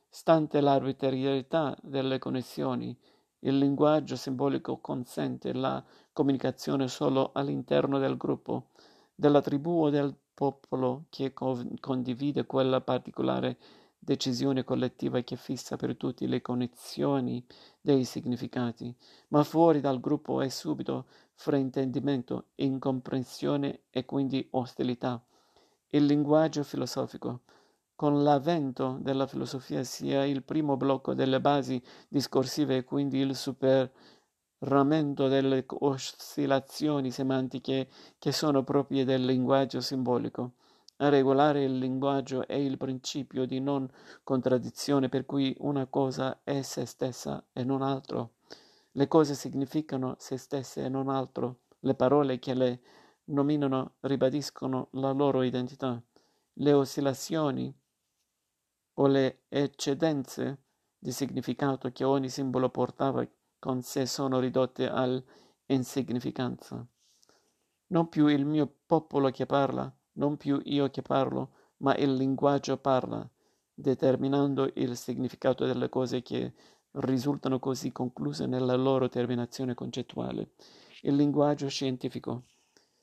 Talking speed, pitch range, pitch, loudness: 115 wpm, 130-140 Hz, 135 Hz, -30 LUFS